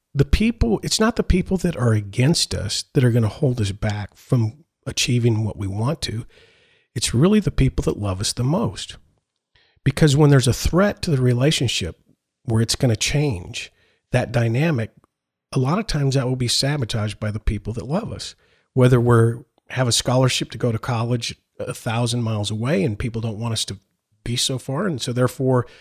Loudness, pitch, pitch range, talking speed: -21 LUFS, 125 Hz, 110-140 Hz, 200 wpm